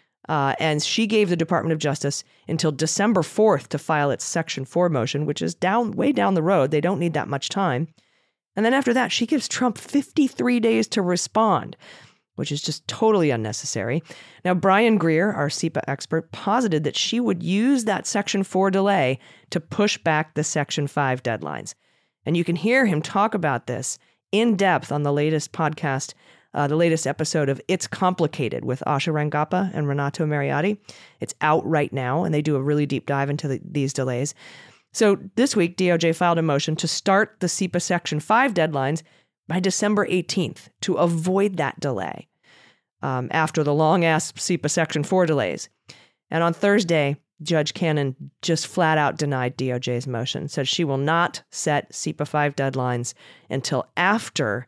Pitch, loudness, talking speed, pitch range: 160 Hz, -22 LUFS, 180 wpm, 145-190 Hz